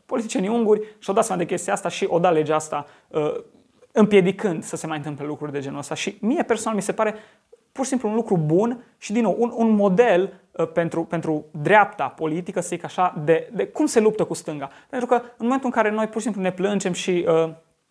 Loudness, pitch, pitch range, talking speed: -22 LUFS, 195 Hz, 165-225 Hz, 225 wpm